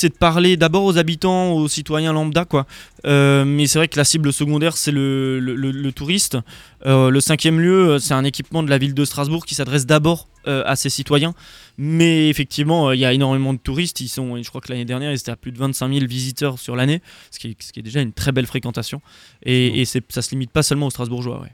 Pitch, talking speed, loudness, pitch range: 140 Hz, 250 wpm, -18 LUFS, 130-155 Hz